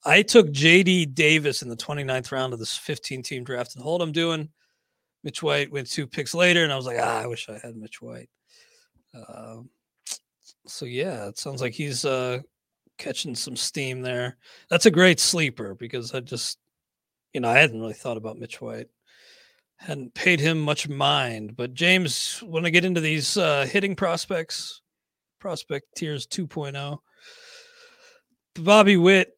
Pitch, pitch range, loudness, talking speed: 145 Hz, 125-175 Hz, -22 LUFS, 170 wpm